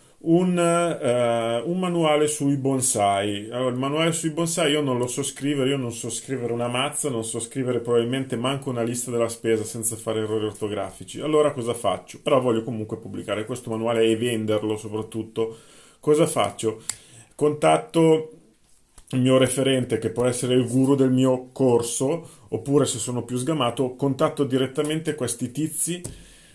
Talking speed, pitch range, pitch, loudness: 160 wpm, 115-145 Hz, 125 Hz, -23 LUFS